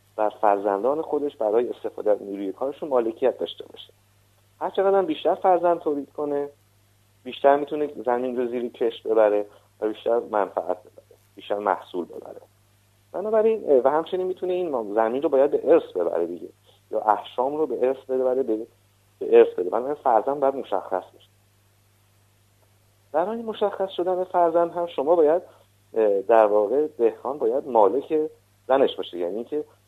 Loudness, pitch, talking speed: -23 LUFS, 145 Hz, 150 wpm